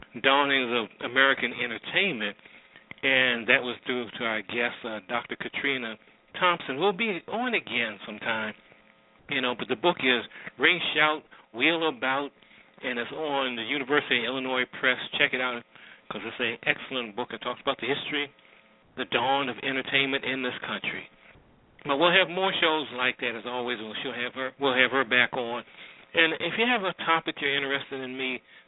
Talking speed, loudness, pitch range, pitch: 180 wpm, -26 LUFS, 125-145 Hz, 130 Hz